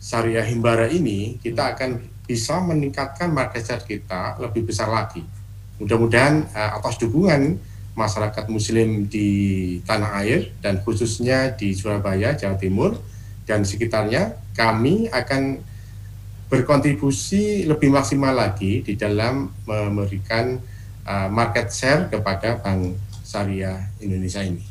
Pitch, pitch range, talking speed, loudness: 110 Hz, 100-120 Hz, 115 wpm, -21 LUFS